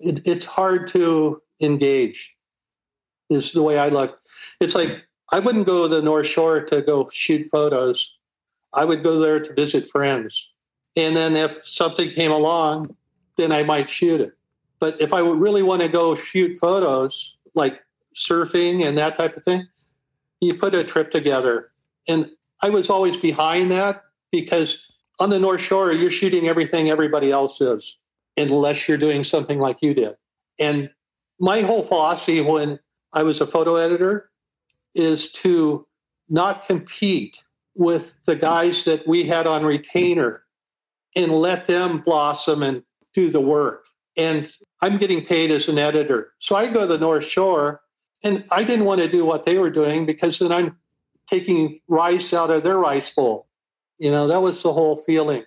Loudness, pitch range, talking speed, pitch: -19 LUFS, 150-180 Hz, 170 wpm, 160 Hz